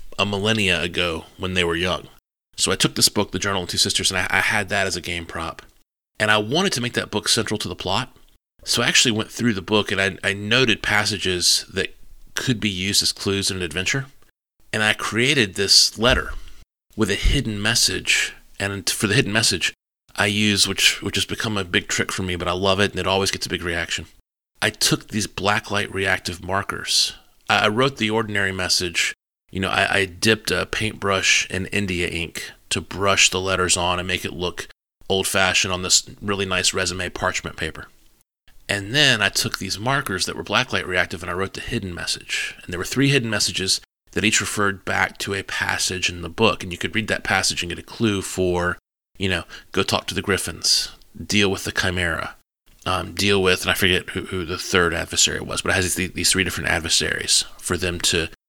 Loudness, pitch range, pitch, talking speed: -20 LUFS, 90-105 Hz, 95 Hz, 215 wpm